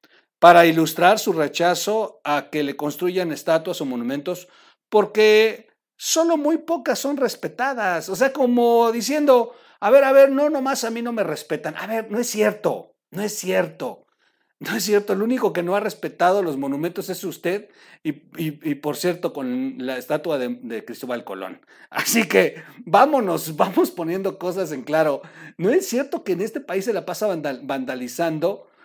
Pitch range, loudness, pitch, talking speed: 165-250 Hz, -21 LUFS, 200 Hz, 175 wpm